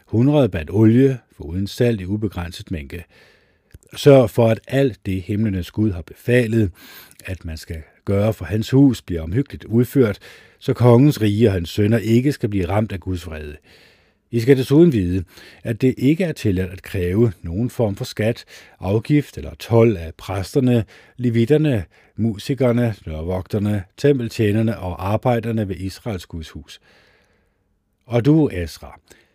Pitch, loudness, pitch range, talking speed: 110 Hz, -19 LUFS, 95-120 Hz, 150 wpm